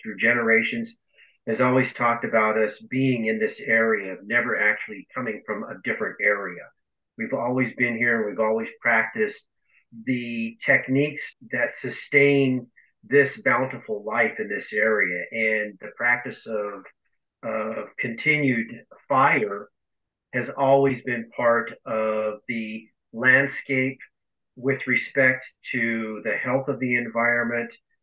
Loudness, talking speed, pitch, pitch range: -23 LUFS, 125 wpm, 120 Hz, 110-135 Hz